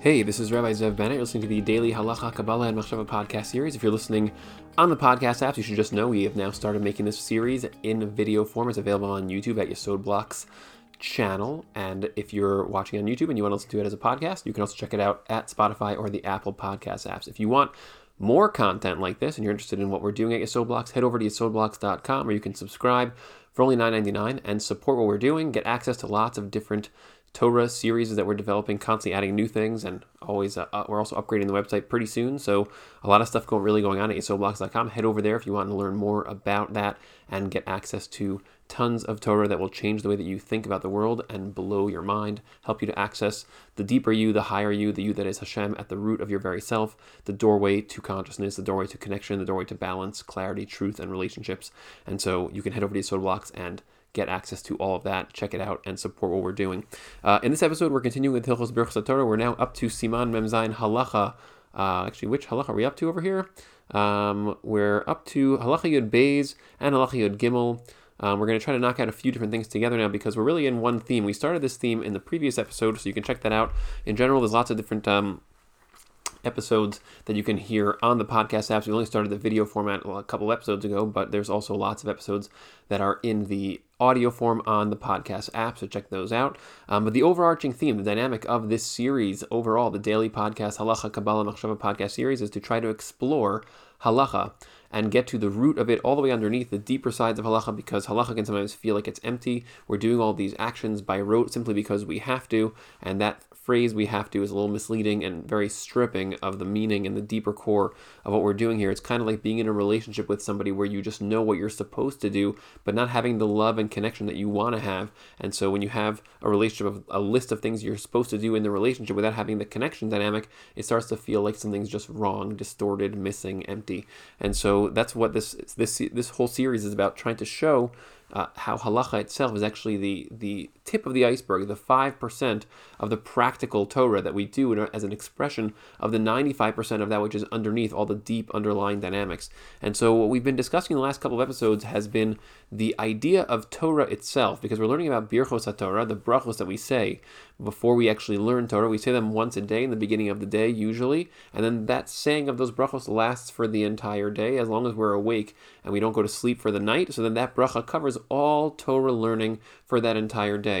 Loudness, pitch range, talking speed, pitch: -26 LUFS, 100-115 Hz, 240 wpm, 110 Hz